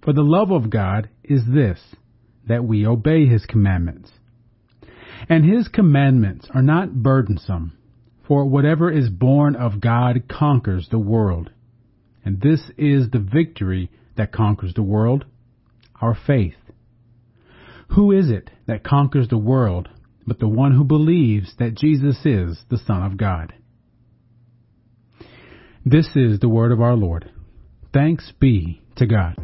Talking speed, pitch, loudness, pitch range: 140 wpm, 120 Hz, -18 LUFS, 110-135 Hz